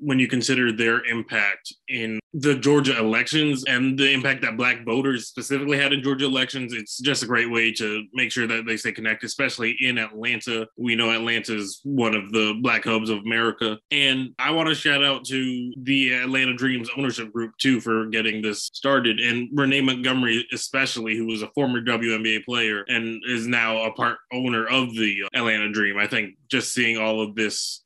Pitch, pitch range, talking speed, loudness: 120 Hz, 110-130 Hz, 195 wpm, -22 LUFS